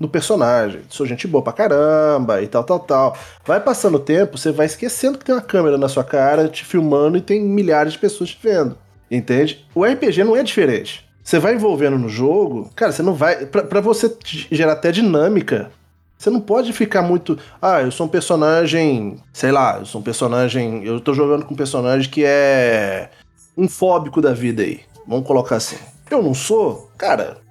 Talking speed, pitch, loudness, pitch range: 200 wpm, 155 Hz, -17 LUFS, 135-185 Hz